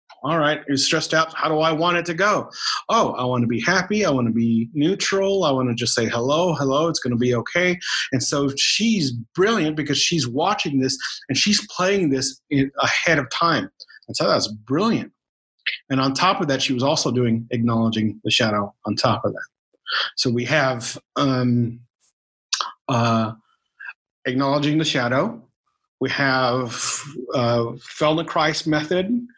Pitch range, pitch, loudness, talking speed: 120-160 Hz, 135 Hz, -21 LUFS, 170 wpm